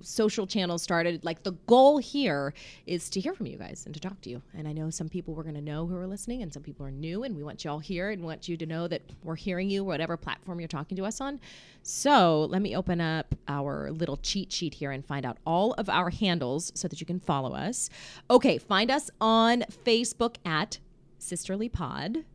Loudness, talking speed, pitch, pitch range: -29 LUFS, 235 wpm, 175 Hz, 160-210 Hz